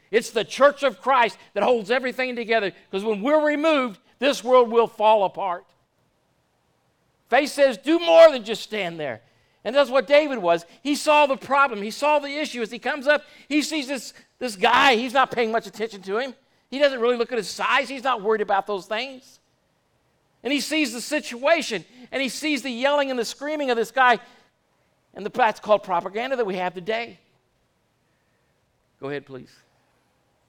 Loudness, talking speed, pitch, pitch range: -22 LUFS, 185 wpm, 245 Hz, 215-280 Hz